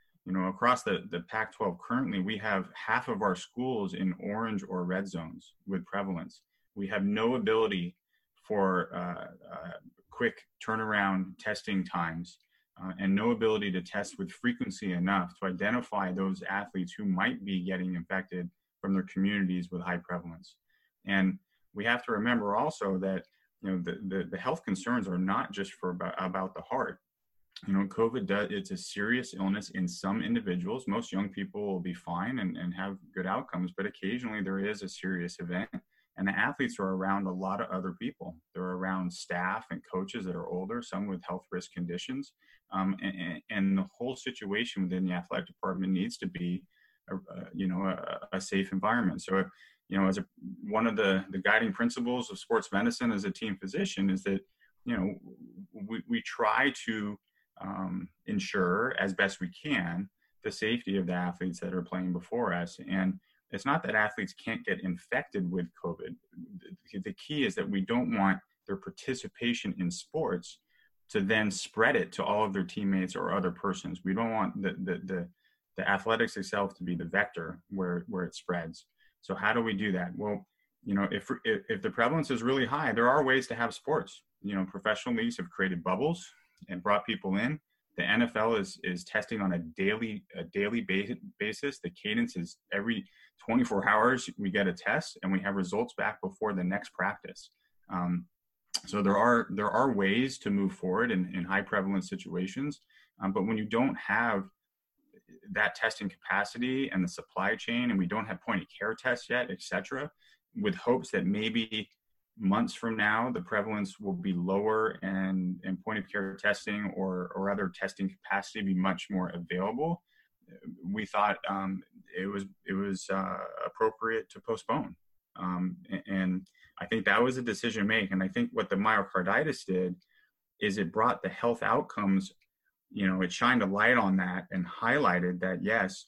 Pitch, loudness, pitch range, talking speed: 95 Hz, -32 LUFS, 95-120 Hz, 185 wpm